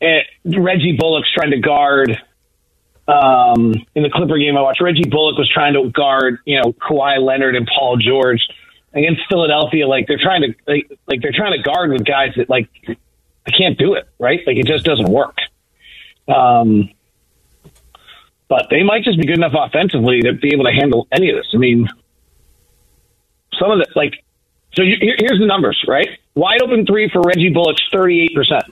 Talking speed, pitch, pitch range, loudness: 190 wpm, 145 Hz, 120-165 Hz, -14 LUFS